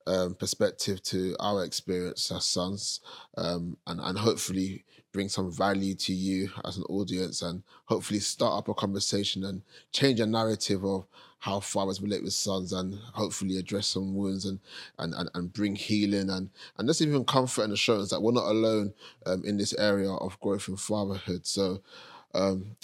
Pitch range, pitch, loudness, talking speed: 95-105 Hz, 95 Hz, -30 LUFS, 175 wpm